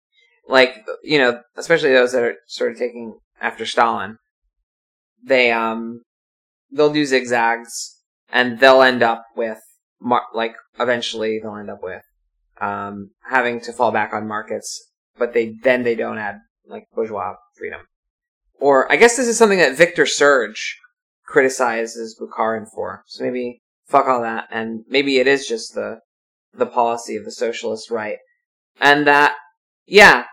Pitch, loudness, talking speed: 125 Hz, -17 LUFS, 150 wpm